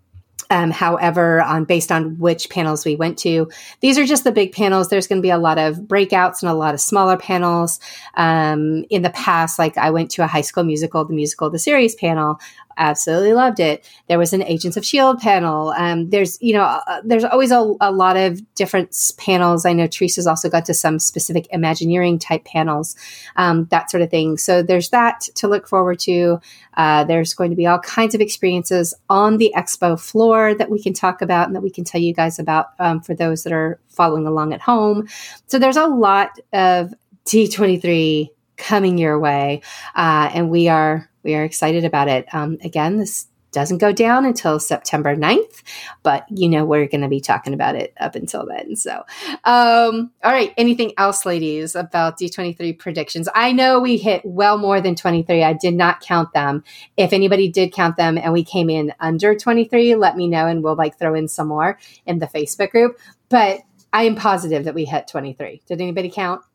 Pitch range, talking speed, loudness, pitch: 160-200 Hz, 205 wpm, -17 LUFS, 175 Hz